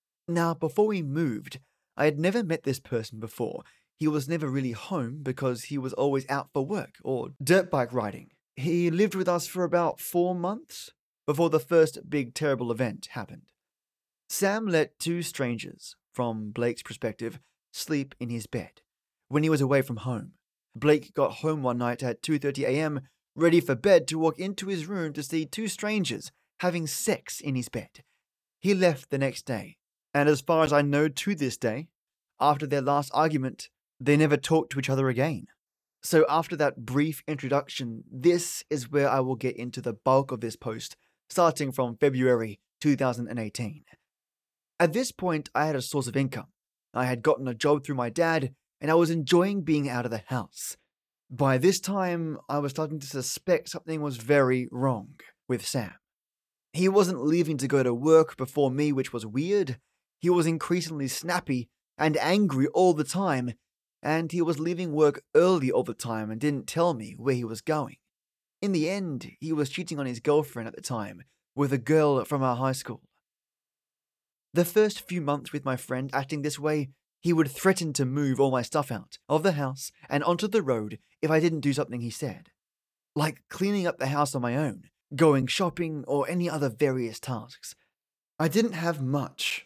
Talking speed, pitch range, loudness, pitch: 185 wpm, 125-160 Hz, -27 LUFS, 145 Hz